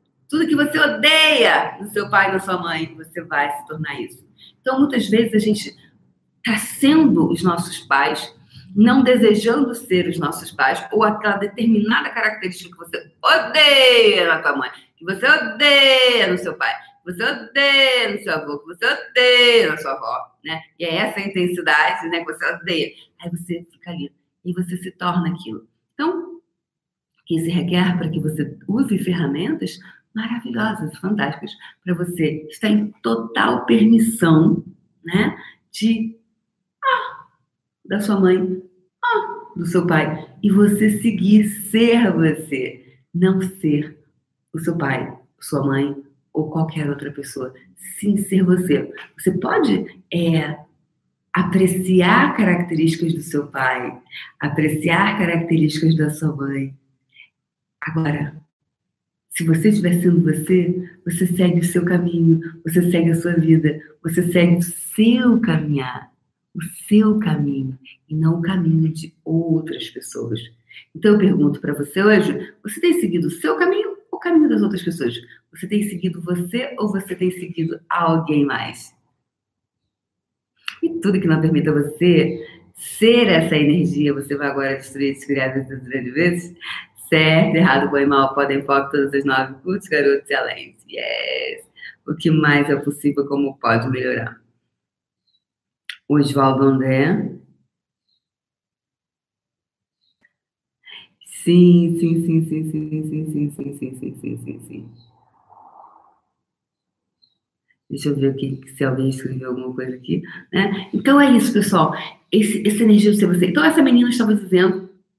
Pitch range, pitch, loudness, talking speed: 150-205 Hz, 170 Hz, -18 LUFS, 140 wpm